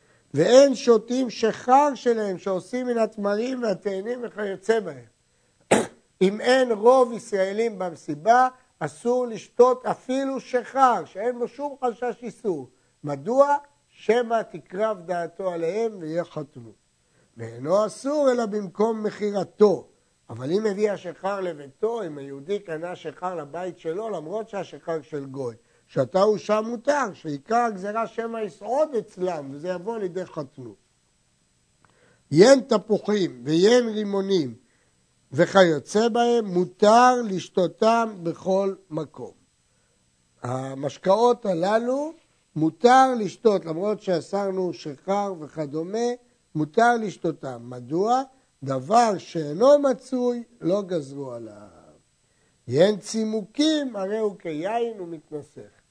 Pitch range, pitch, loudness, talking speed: 160-235 Hz, 200 Hz, -23 LUFS, 105 wpm